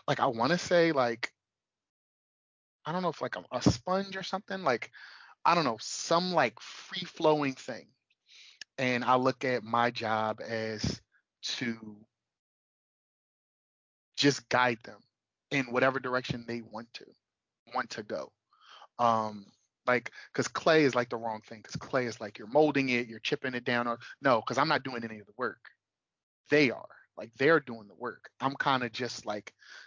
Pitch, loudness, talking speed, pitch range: 125 Hz, -30 LUFS, 175 wpm, 115-145 Hz